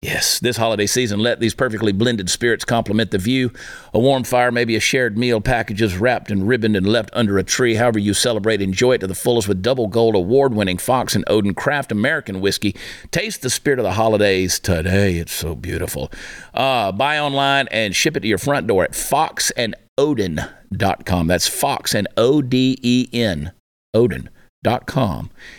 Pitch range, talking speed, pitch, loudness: 100-125 Hz, 165 wpm, 115 Hz, -18 LUFS